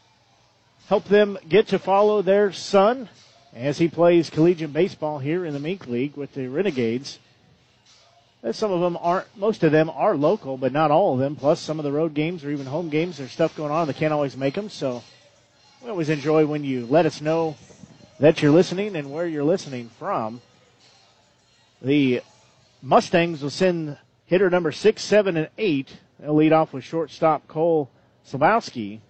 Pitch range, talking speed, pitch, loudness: 140-175 Hz, 180 wpm, 155 Hz, -22 LUFS